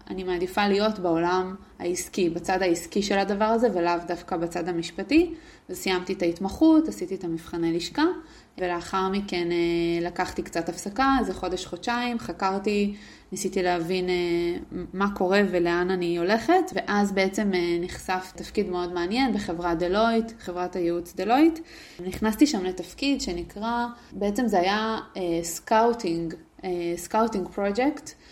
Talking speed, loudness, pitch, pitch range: 125 wpm, -26 LUFS, 185 Hz, 175-215 Hz